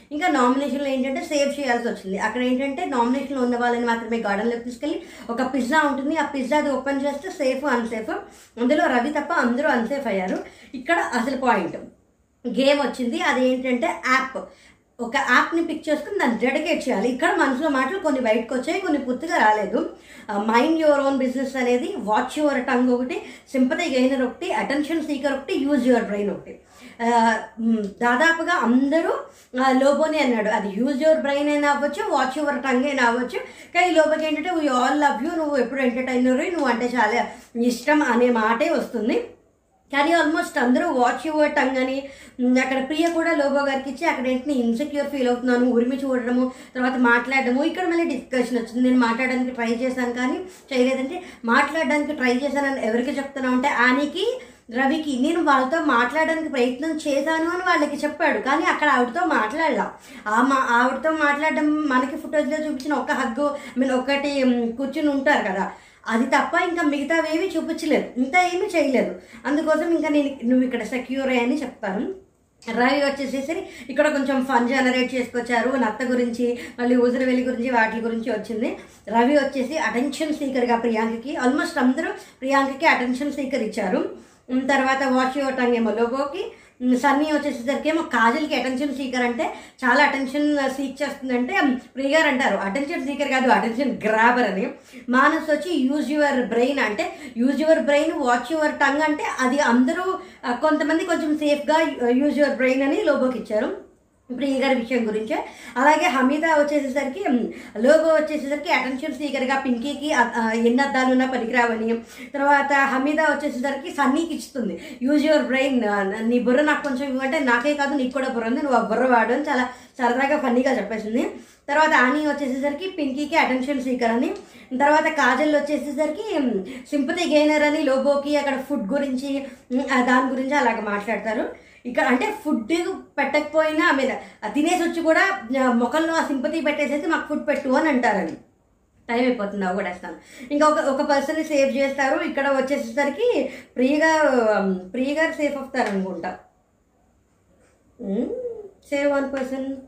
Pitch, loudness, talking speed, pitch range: 275 Hz, -21 LUFS, 145 wpm, 250-295 Hz